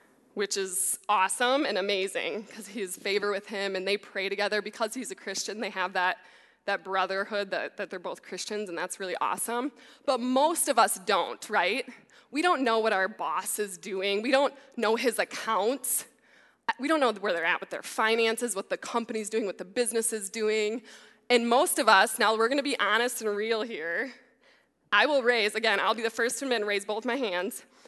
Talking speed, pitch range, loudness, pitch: 210 wpm, 200-245 Hz, -28 LUFS, 220 Hz